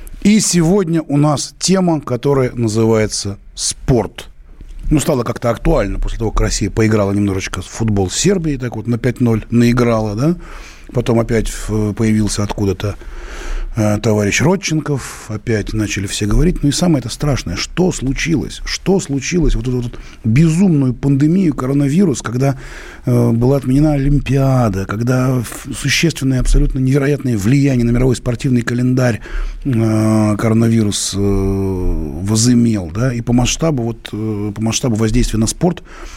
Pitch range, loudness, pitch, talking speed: 110-140 Hz, -15 LUFS, 120 Hz, 140 wpm